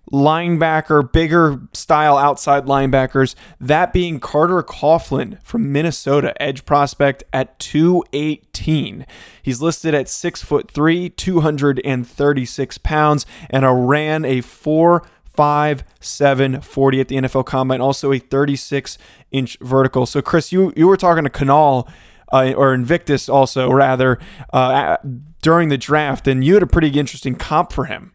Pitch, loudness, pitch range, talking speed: 145 Hz, -16 LUFS, 135-155 Hz, 140 wpm